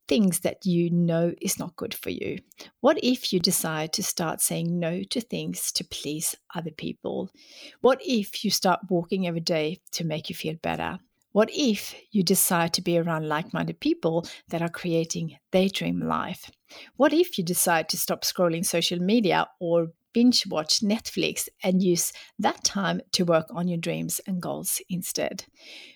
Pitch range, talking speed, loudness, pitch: 165-205 Hz, 175 wpm, -26 LUFS, 180 Hz